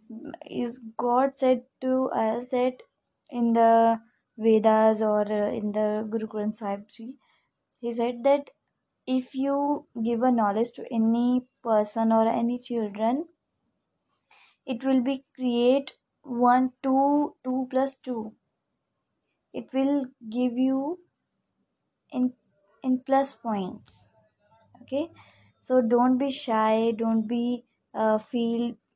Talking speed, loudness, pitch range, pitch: 115 wpm, -26 LUFS, 225-260 Hz, 245 Hz